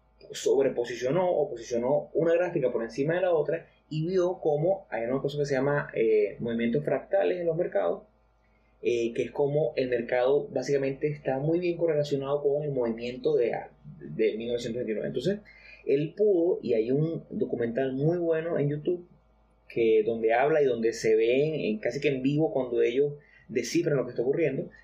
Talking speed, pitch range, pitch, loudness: 175 wpm, 130-180 Hz, 145 Hz, -28 LUFS